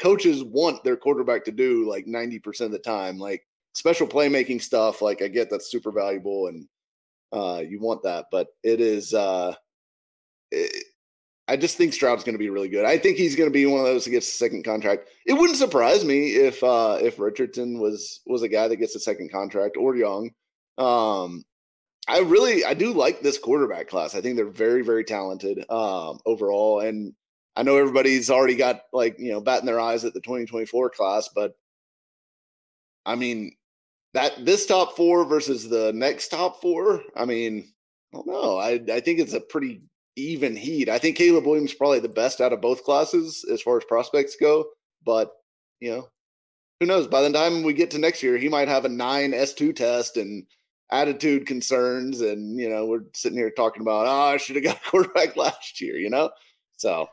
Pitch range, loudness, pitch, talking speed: 115-180 Hz, -23 LUFS, 135 Hz, 200 wpm